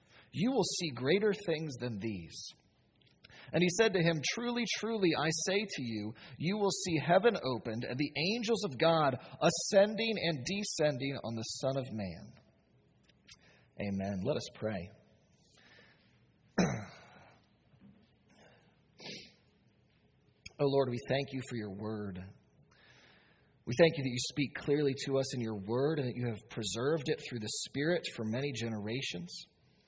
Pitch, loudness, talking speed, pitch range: 140 Hz, -34 LUFS, 145 wpm, 115-170 Hz